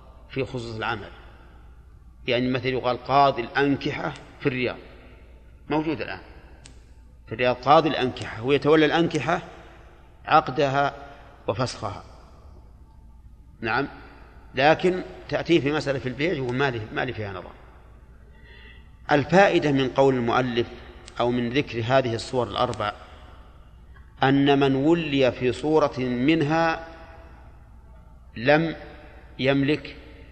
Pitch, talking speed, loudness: 125 Hz, 105 wpm, -23 LUFS